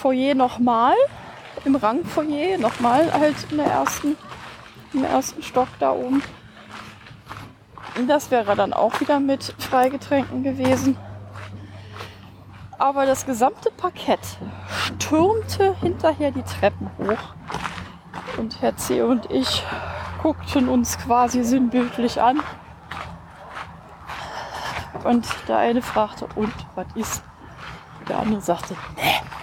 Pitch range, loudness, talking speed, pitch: 175-280 Hz, -22 LUFS, 105 wpm, 250 Hz